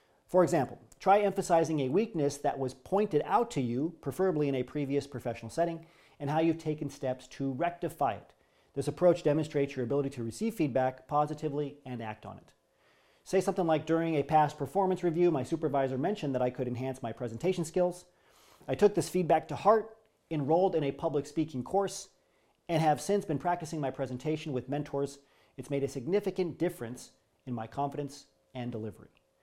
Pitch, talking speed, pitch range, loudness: 150 Hz, 180 wpm, 135-170 Hz, -31 LUFS